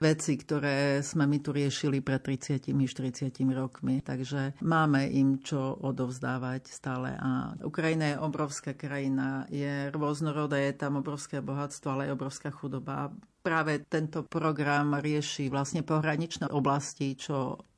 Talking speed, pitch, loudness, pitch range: 130 wpm, 140 Hz, -31 LUFS, 135-150 Hz